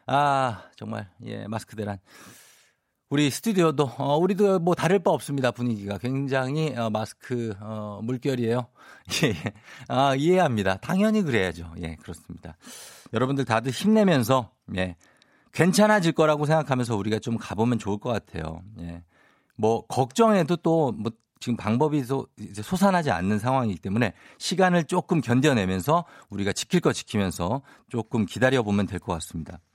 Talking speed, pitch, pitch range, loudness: 325 characters per minute, 120 Hz, 105-150 Hz, -25 LUFS